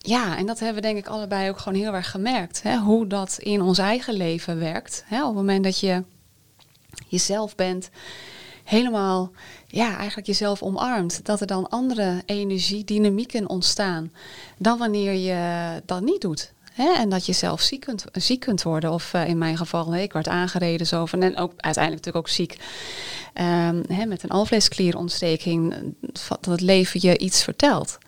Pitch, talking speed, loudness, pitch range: 190 Hz, 180 wpm, -23 LUFS, 175-215 Hz